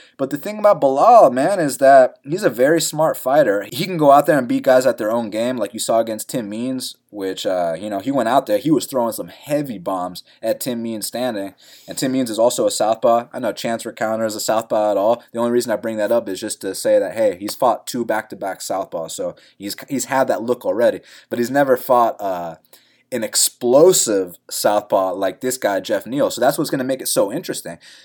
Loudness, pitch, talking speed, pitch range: -18 LUFS, 125 Hz, 245 wpm, 110-155 Hz